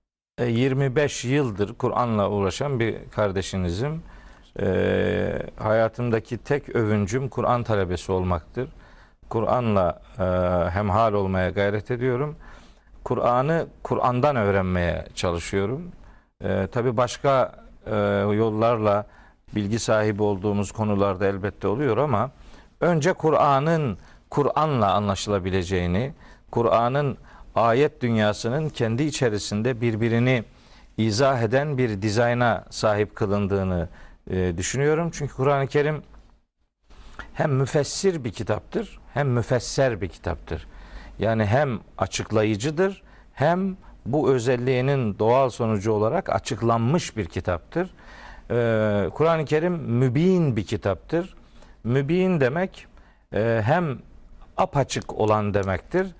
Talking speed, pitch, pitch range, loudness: 90 wpm, 115 Hz, 100-140 Hz, -24 LUFS